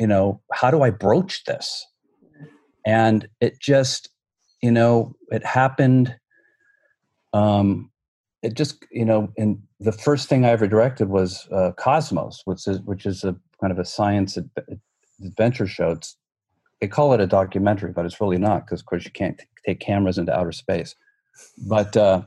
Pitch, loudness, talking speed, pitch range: 110 Hz, -21 LUFS, 170 wpm, 100-130 Hz